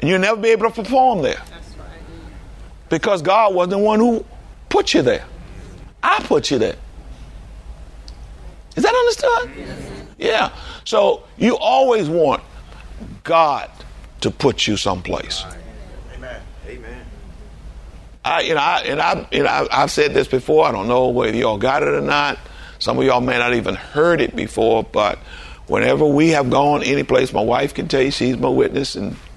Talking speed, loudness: 170 wpm, -17 LUFS